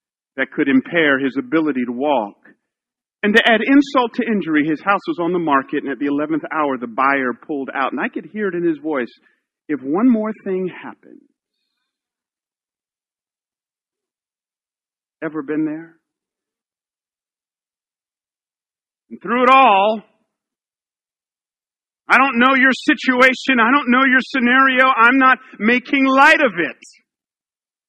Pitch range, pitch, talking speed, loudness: 155-260 Hz, 210 Hz, 140 wpm, -16 LUFS